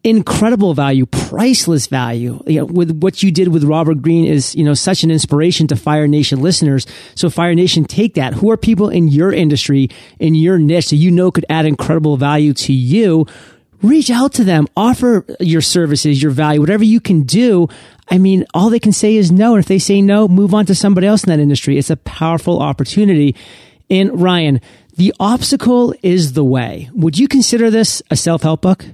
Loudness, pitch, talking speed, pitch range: -12 LUFS, 170 Hz, 205 wpm, 150-200 Hz